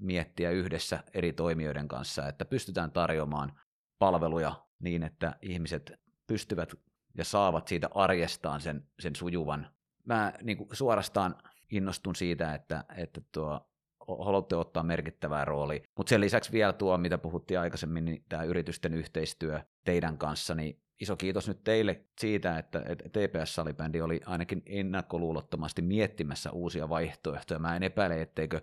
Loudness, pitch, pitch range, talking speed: -33 LUFS, 85 Hz, 80-95 Hz, 135 wpm